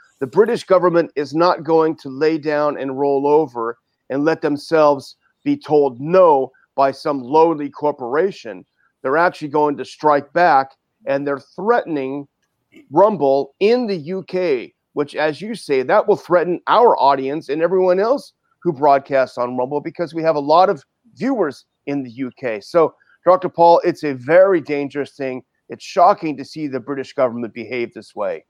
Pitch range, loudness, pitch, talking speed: 135-175 Hz, -18 LUFS, 150 Hz, 165 wpm